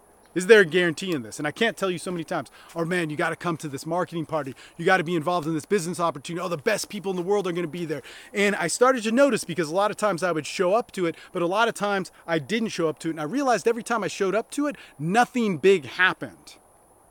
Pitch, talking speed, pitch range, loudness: 180 Hz, 300 wpm, 165-205 Hz, -24 LUFS